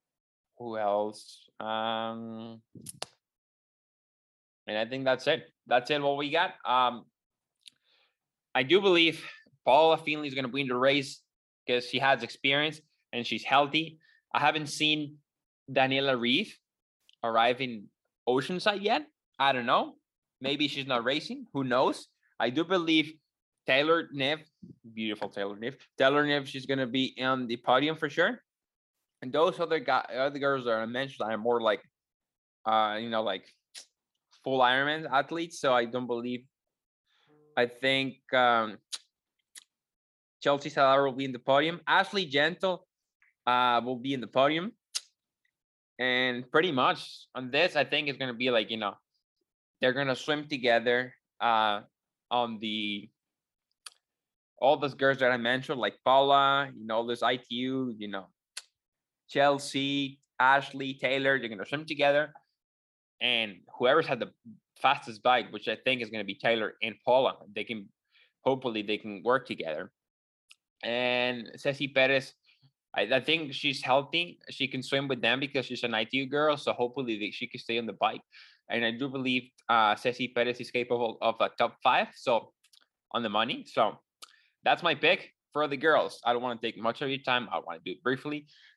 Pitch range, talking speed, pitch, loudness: 115-145 Hz, 165 wpm, 130 Hz, -29 LUFS